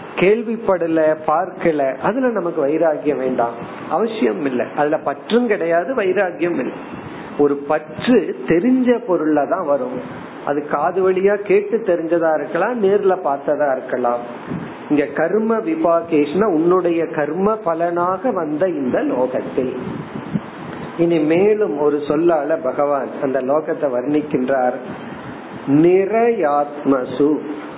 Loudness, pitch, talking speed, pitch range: -18 LUFS, 160 Hz, 95 wpm, 145-190 Hz